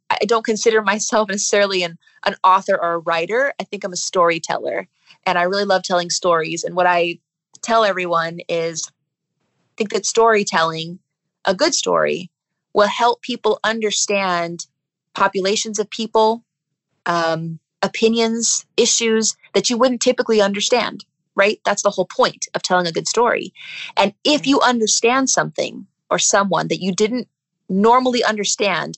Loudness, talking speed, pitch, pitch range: -18 LUFS, 150 wpm, 195 Hz, 170-220 Hz